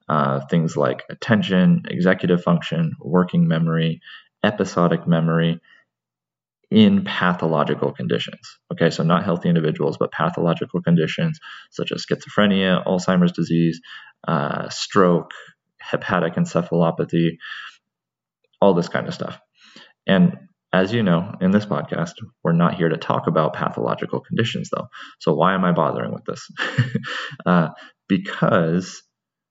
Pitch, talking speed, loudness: 90 Hz, 120 wpm, -20 LUFS